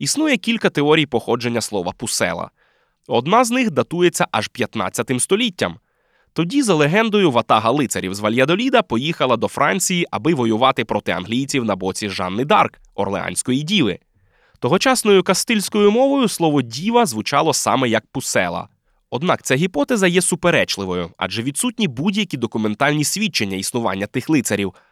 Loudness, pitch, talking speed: -18 LUFS, 145 Hz, 130 wpm